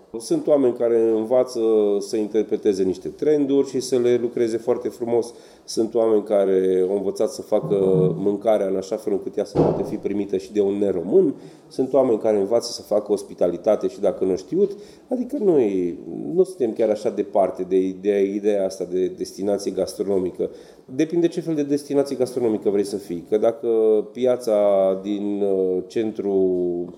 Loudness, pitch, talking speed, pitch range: -21 LUFS, 110 Hz, 165 wpm, 100-140 Hz